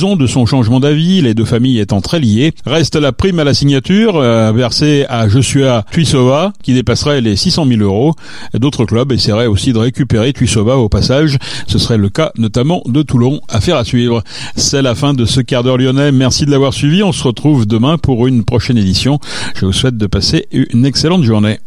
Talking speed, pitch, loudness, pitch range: 205 wpm, 130 Hz, -11 LUFS, 115-145 Hz